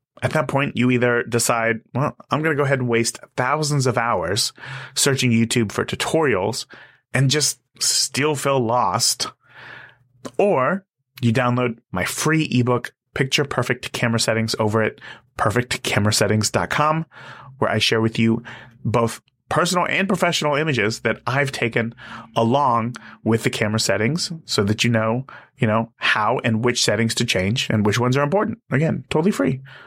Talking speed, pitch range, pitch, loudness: 155 wpm, 115-140 Hz, 125 Hz, -20 LUFS